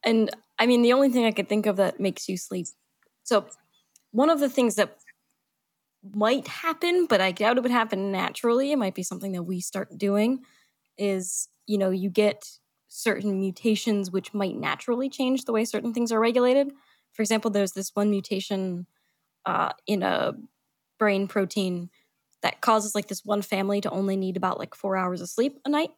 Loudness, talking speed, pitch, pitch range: -26 LUFS, 190 wpm, 210 Hz, 195-235 Hz